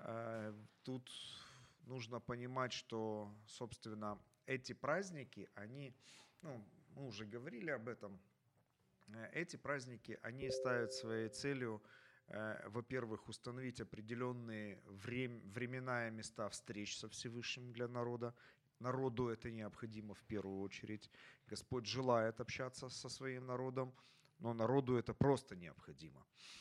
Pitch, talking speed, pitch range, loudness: 120 Hz, 115 wpm, 110-130 Hz, -46 LUFS